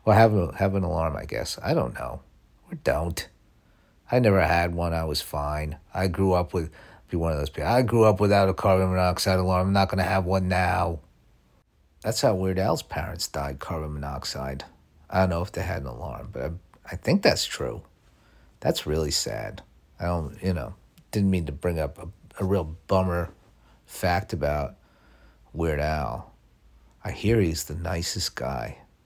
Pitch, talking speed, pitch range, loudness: 90 Hz, 190 wpm, 75-95 Hz, -26 LUFS